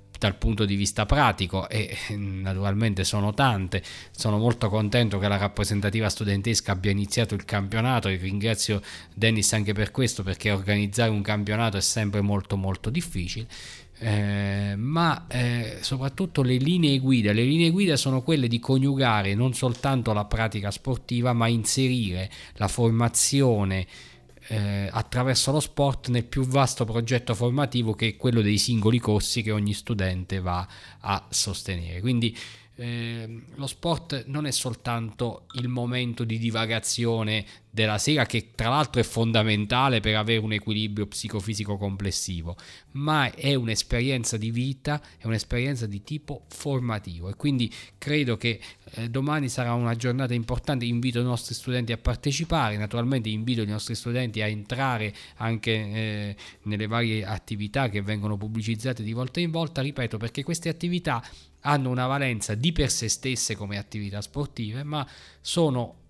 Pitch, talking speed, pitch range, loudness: 115 Hz, 150 wpm, 105-125 Hz, -26 LUFS